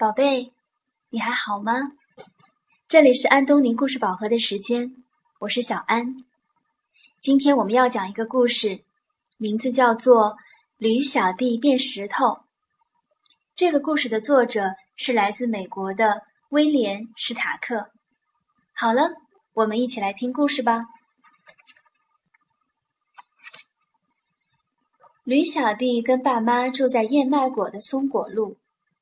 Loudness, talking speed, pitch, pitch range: -21 LUFS, 180 characters per minute, 250 Hz, 225-295 Hz